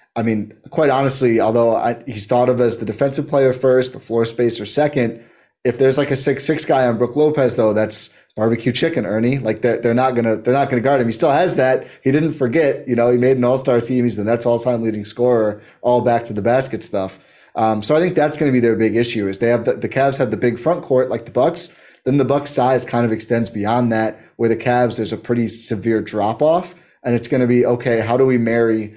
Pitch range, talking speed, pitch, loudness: 115-130 Hz, 255 wpm, 120 Hz, -17 LUFS